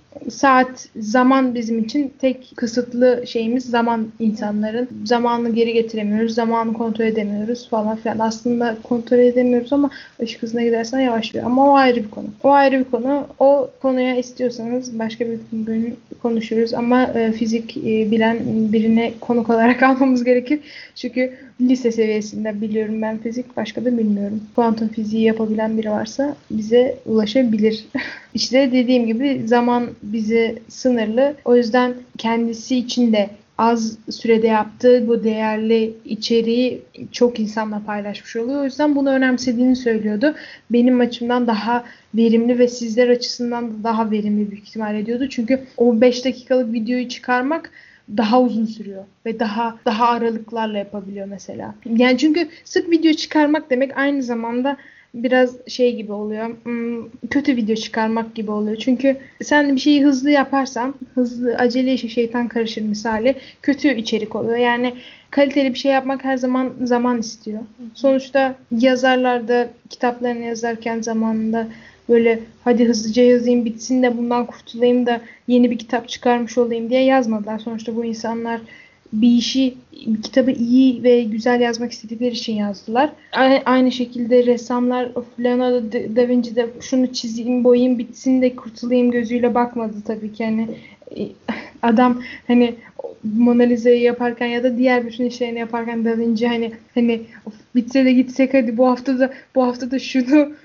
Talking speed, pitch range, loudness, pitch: 145 wpm, 230-255 Hz, -18 LUFS, 240 Hz